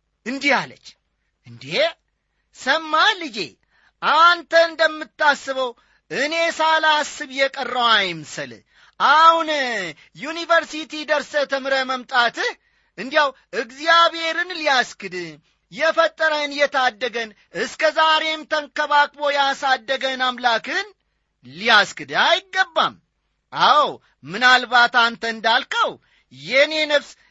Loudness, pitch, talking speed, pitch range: -18 LUFS, 290 Hz, 75 wpm, 250-320 Hz